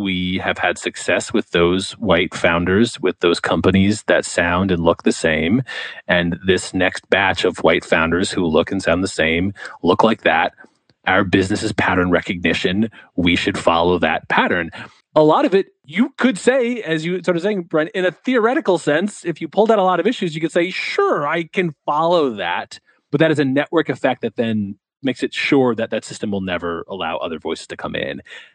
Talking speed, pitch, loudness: 205 wpm, 145 Hz, -18 LUFS